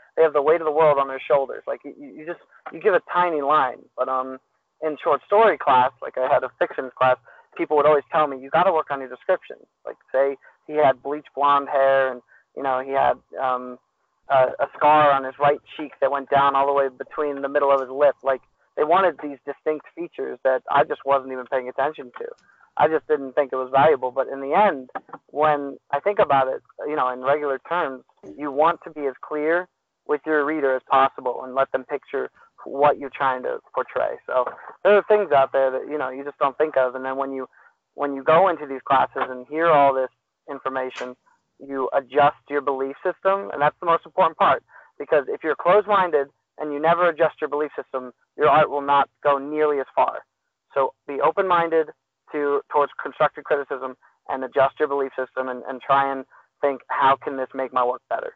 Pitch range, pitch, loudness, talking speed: 135-155 Hz, 140 Hz, -22 LUFS, 220 wpm